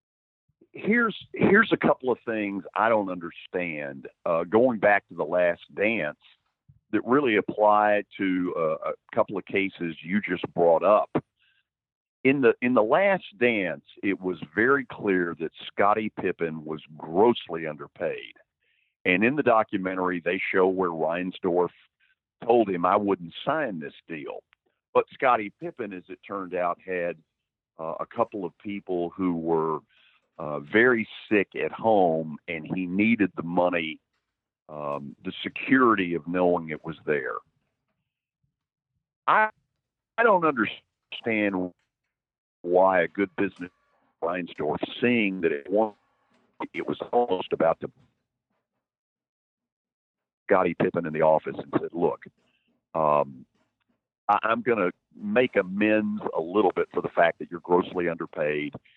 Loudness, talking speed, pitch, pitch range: -25 LUFS, 140 wpm, 95 Hz, 85-110 Hz